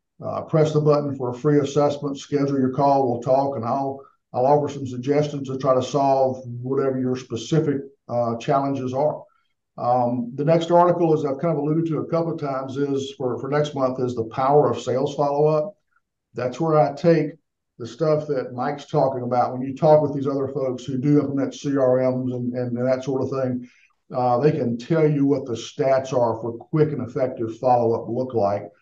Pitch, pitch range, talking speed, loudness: 135 Hz, 125-145 Hz, 210 wpm, -22 LUFS